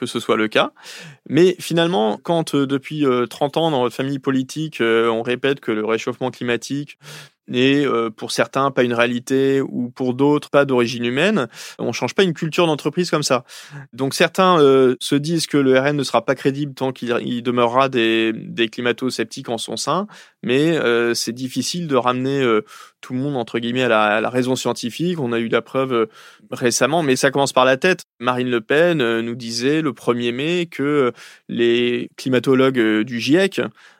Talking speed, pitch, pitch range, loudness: 195 wpm, 130 Hz, 120-145 Hz, -19 LUFS